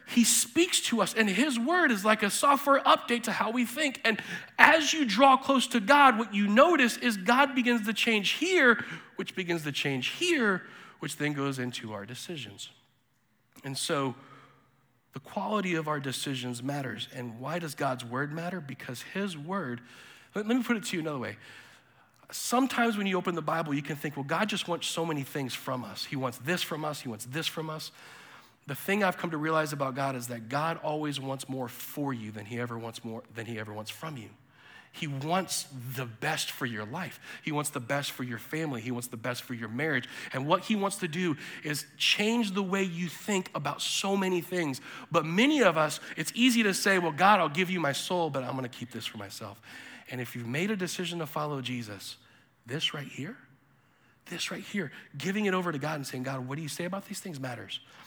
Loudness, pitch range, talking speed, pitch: -29 LUFS, 130-200 Hz, 220 wpm, 155 Hz